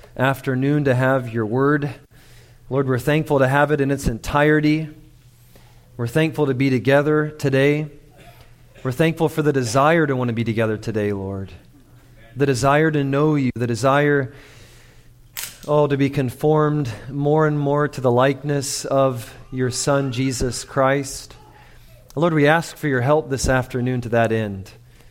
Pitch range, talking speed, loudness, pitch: 125-145 Hz, 160 wpm, -19 LUFS, 135 Hz